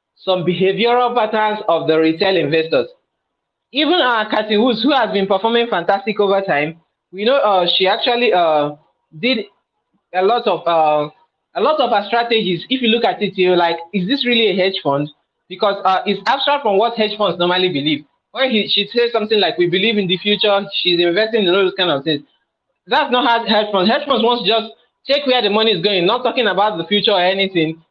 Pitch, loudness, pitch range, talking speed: 200 Hz, -16 LUFS, 180-230 Hz, 220 wpm